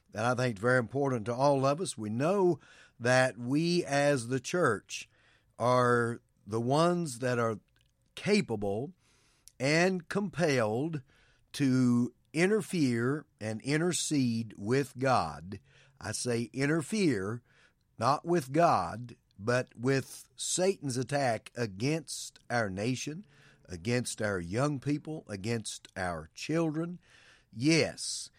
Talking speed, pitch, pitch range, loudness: 110 wpm, 130 Hz, 115-150 Hz, -31 LUFS